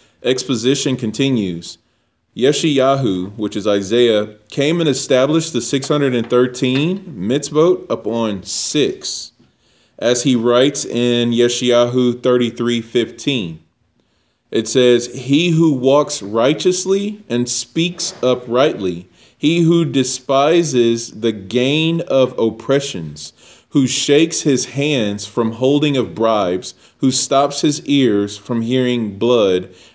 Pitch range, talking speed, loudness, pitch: 115-140 Hz, 110 wpm, -16 LUFS, 125 Hz